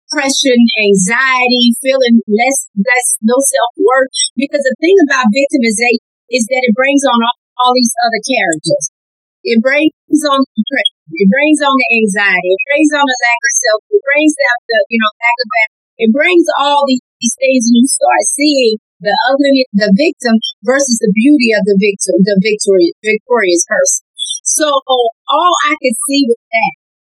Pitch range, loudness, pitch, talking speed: 220-280 Hz, -11 LUFS, 250 Hz, 175 wpm